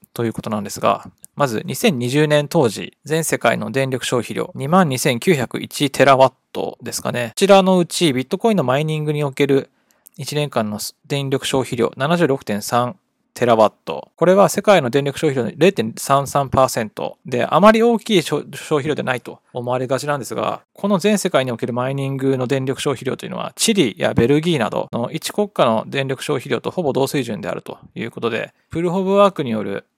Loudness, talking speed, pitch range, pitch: -18 LUFS, 345 characters per minute, 130-175 Hz, 145 Hz